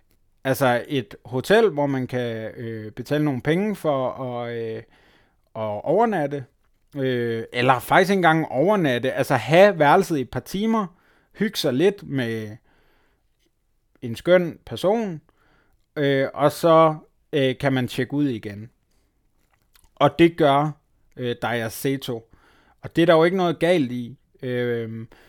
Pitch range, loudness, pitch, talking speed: 120-160 Hz, -21 LUFS, 135 Hz, 140 wpm